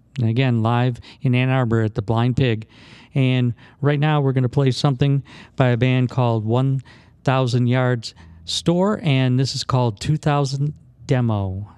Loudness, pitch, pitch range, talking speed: -20 LUFS, 125 Hz, 115-135 Hz, 160 wpm